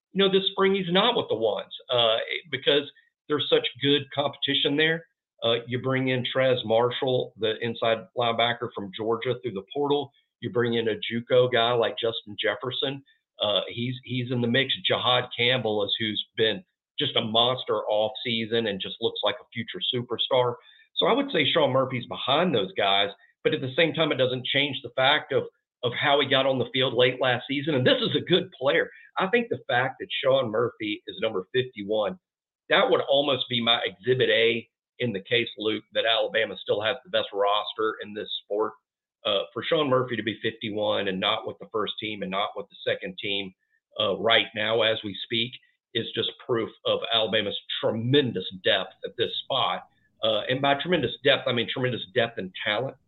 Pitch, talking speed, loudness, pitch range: 125 Hz, 200 wpm, -25 LUFS, 115-155 Hz